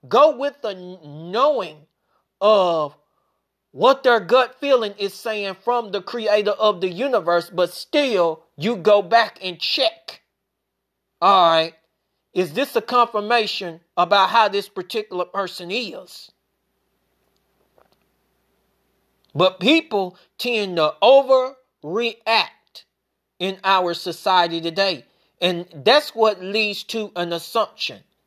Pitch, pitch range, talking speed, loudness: 200 Hz, 175-230 Hz, 110 wpm, -20 LUFS